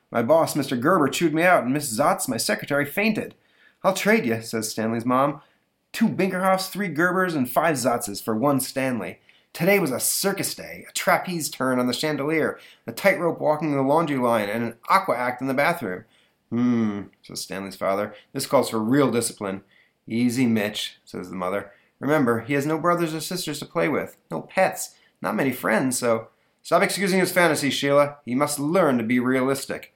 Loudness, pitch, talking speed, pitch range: -23 LUFS, 145 Hz, 190 wpm, 120-175 Hz